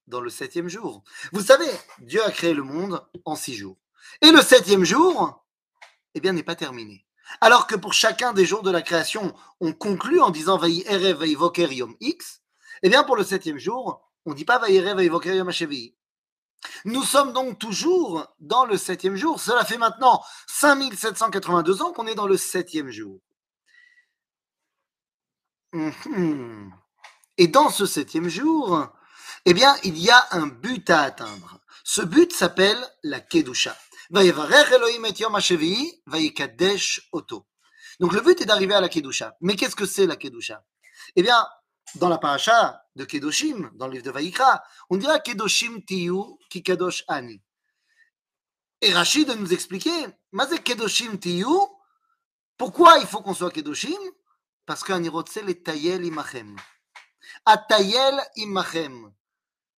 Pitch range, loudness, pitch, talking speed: 170-285 Hz, -20 LUFS, 195 Hz, 155 wpm